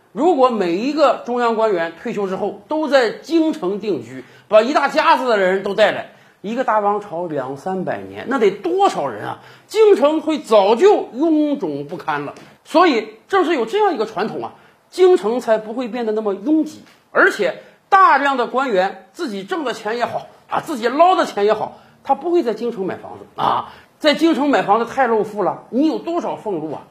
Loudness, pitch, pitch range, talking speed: -17 LUFS, 245 Hz, 205-315 Hz, 280 characters per minute